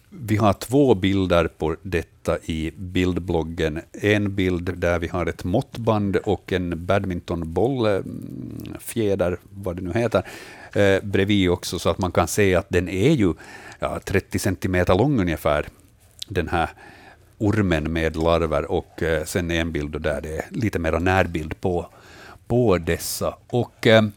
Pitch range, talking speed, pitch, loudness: 85-100 Hz, 150 wpm, 90 Hz, -22 LUFS